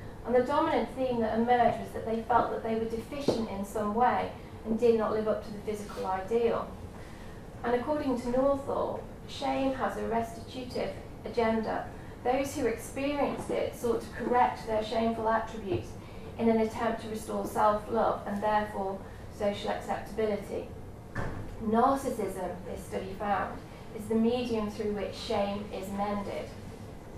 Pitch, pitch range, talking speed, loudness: 225 Hz, 210-245 Hz, 150 wpm, -31 LUFS